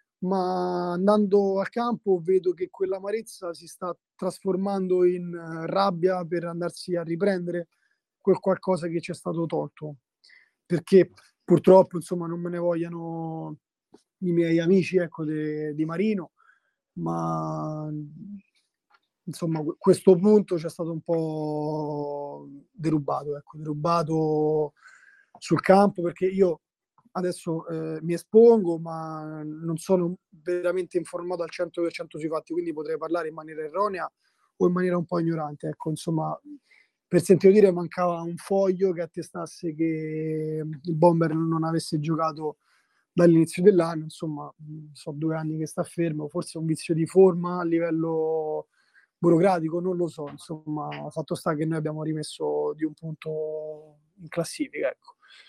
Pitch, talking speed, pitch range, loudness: 170 Hz, 140 wpm, 155-185 Hz, -25 LUFS